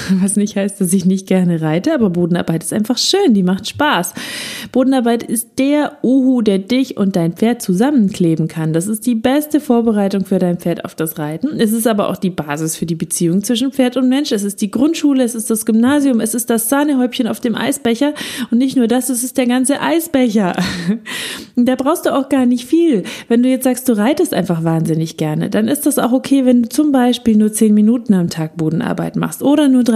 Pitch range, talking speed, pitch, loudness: 190-260 Hz, 220 wpm, 235 Hz, -15 LUFS